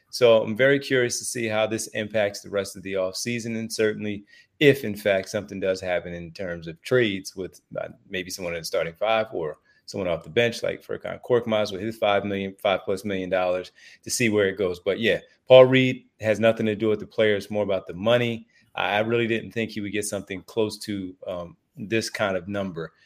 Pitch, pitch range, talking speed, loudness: 105 Hz, 95-115 Hz, 225 wpm, -24 LUFS